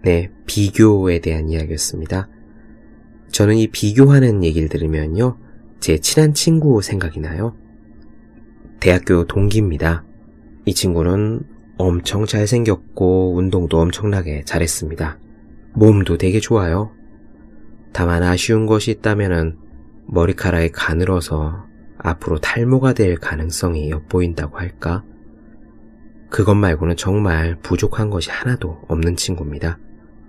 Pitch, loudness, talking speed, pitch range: 95 Hz, -17 LUFS, 265 characters per minute, 80-110 Hz